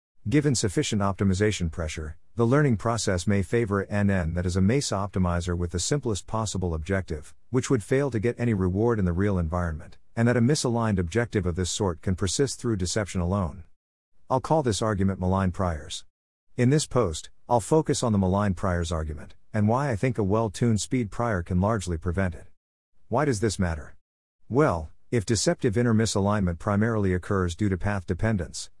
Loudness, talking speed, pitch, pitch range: -26 LUFS, 185 wpm, 100 Hz, 90-115 Hz